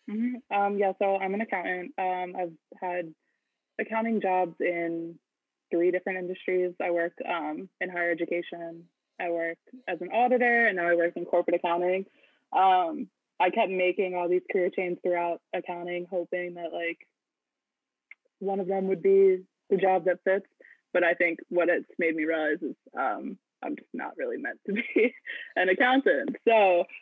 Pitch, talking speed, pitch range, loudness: 180 Hz, 170 wpm, 175-195 Hz, -28 LUFS